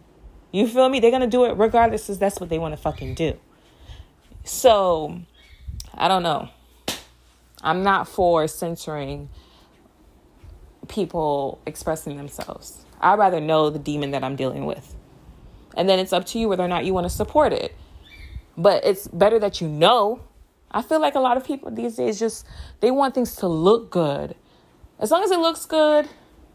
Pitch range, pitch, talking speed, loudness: 145-235 Hz, 180 Hz, 175 wpm, -21 LUFS